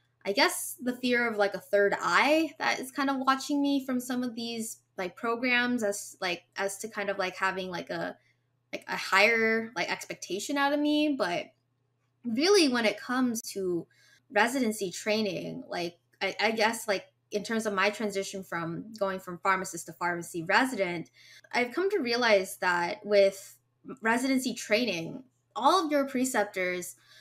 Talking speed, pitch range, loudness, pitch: 170 wpm, 185-250 Hz, -29 LUFS, 210 Hz